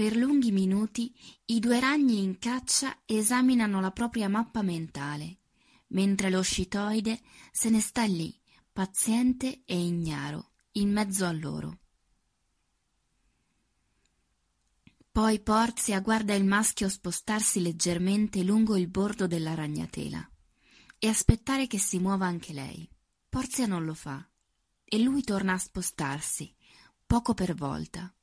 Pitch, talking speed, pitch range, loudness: 200 Hz, 125 wpm, 170-225 Hz, -27 LUFS